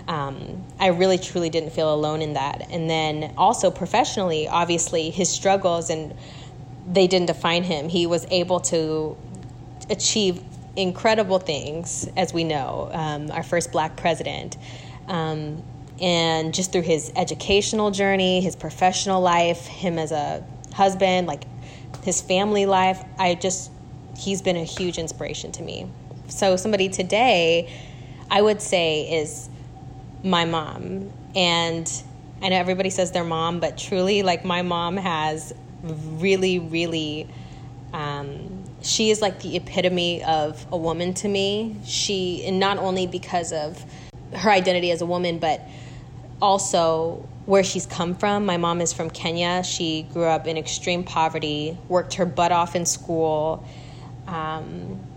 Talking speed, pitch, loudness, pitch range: 145 wpm, 170 Hz, -23 LUFS, 155-185 Hz